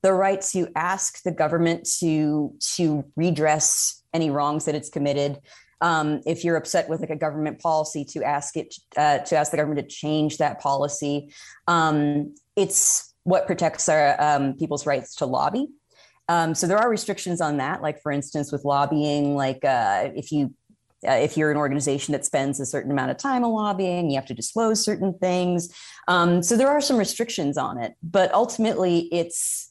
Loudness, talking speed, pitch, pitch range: -23 LUFS, 185 wpm, 155 Hz, 145-180 Hz